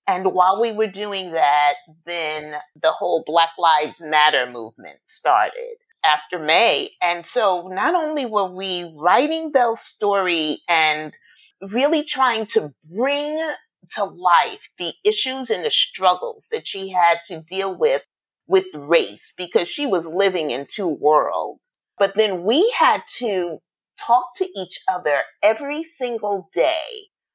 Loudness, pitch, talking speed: -20 LUFS, 195 Hz, 140 wpm